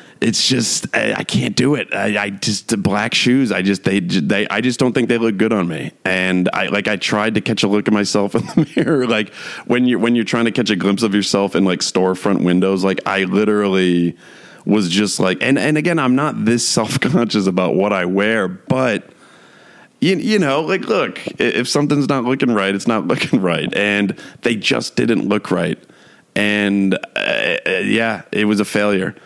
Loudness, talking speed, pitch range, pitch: -16 LUFS, 205 wpm, 100-120 Hz, 105 Hz